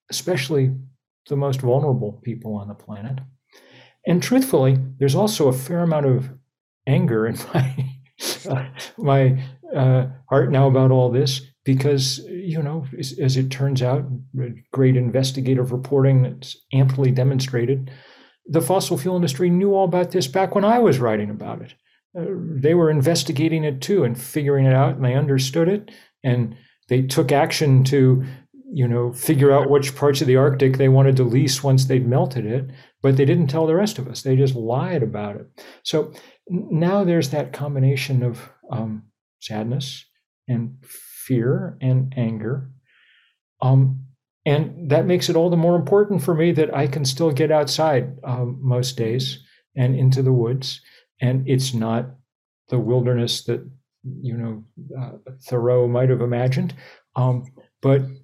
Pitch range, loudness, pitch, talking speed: 125-150 Hz, -20 LUFS, 135 Hz, 160 wpm